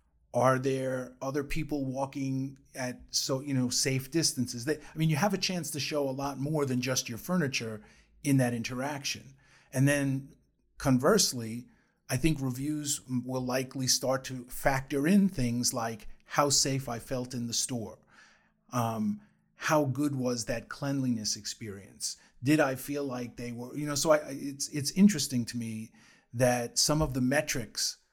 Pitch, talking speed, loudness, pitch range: 135 Hz, 165 wpm, -30 LUFS, 125-145 Hz